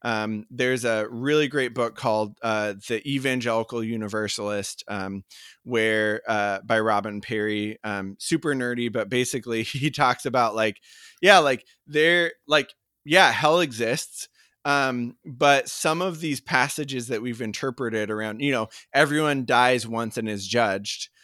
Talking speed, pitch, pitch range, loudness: 145 wpm, 120 Hz, 110-140 Hz, -24 LUFS